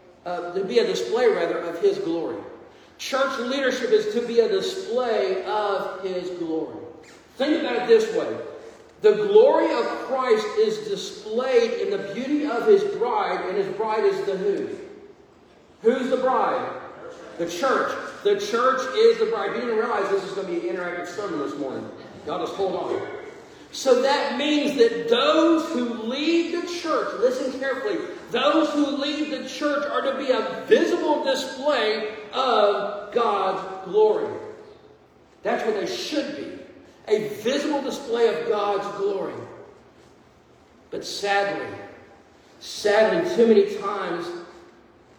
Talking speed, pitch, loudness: 145 wpm, 280 Hz, -23 LUFS